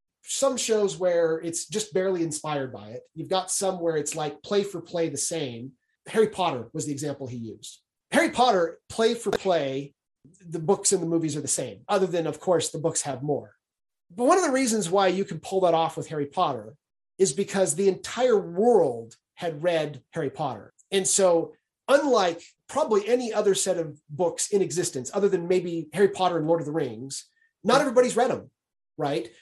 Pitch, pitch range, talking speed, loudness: 175 Hz, 155-200 Hz, 200 wpm, -25 LUFS